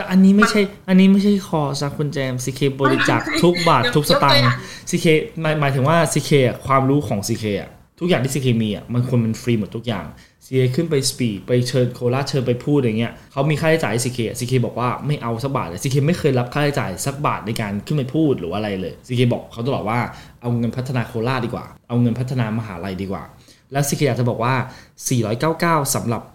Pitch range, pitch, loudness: 120-150 Hz, 130 Hz, -19 LUFS